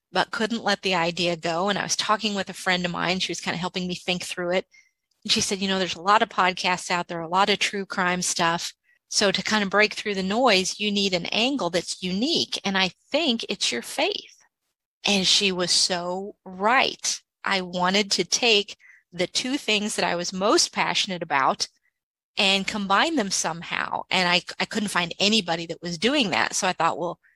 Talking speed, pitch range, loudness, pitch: 215 wpm, 180-210 Hz, -23 LUFS, 190 Hz